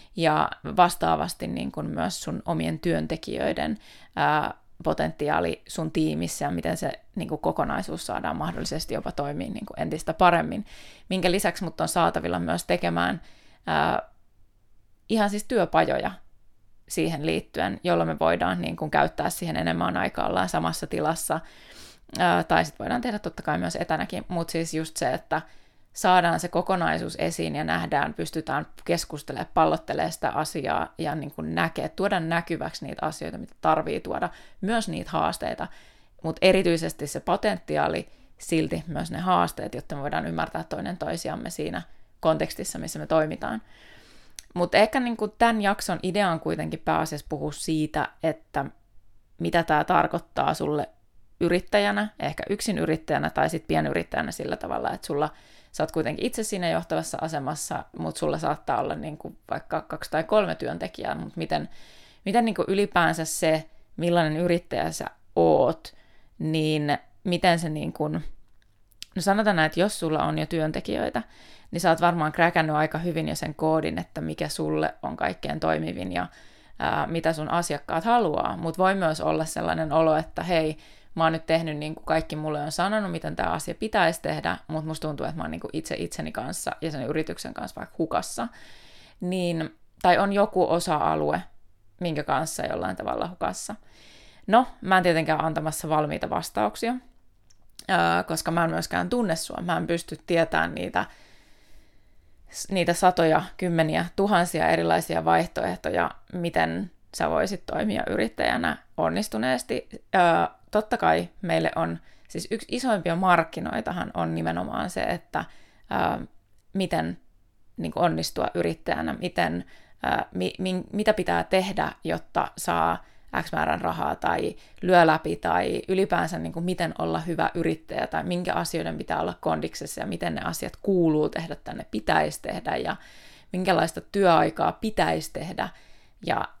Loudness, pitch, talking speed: -26 LUFS, 160 Hz, 150 wpm